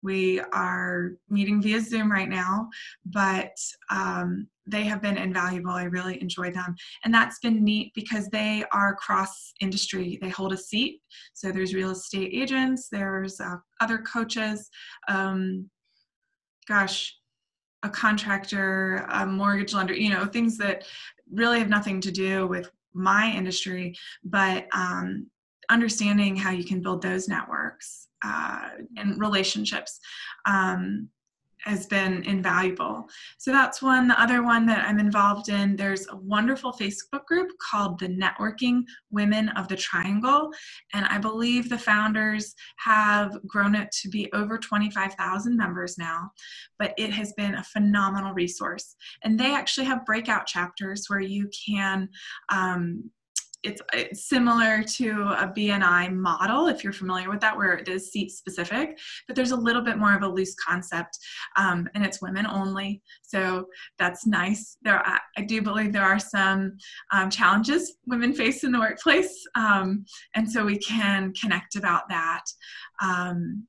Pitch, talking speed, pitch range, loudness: 200 Hz, 150 wpm, 190-220 Hz, -25 LUFS